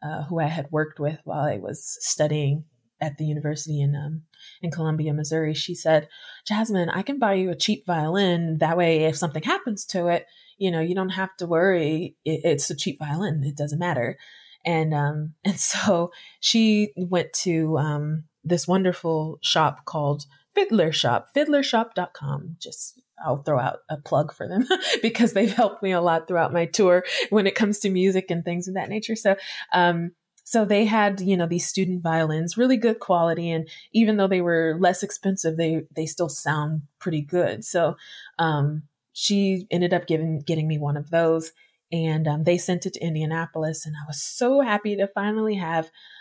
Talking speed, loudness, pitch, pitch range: 190 wpm, -23 LUFS, 170 Hz, 155-190 Hz